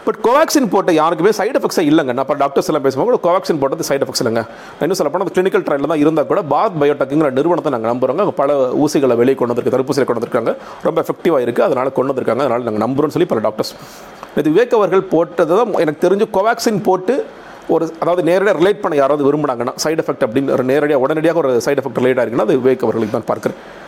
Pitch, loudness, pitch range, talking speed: 170 Hz, -15 LUFS, 145-215 Hz, 195 wpm